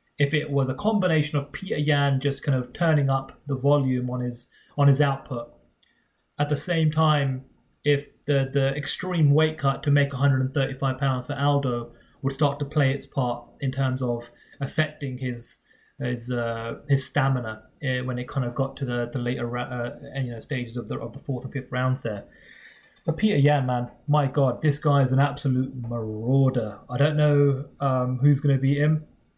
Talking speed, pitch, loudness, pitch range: 190 wpm, 135 Hz, -25 LUFS, 125-145 Hz